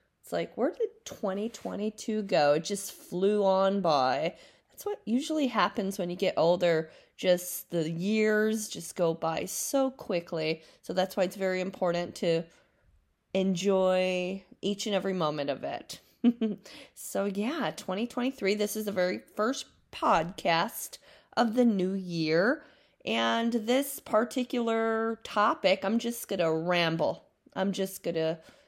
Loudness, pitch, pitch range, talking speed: -29 LUFS, 195 Hz, 175-225 Hz, 140 wpm